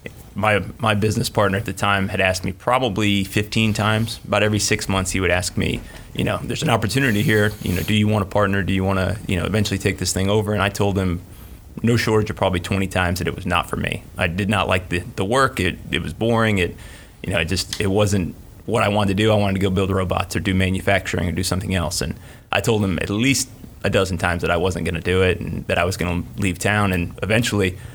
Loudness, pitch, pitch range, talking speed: -20 LUFS, 100 Hz, 95-110 Hz, 260 wpm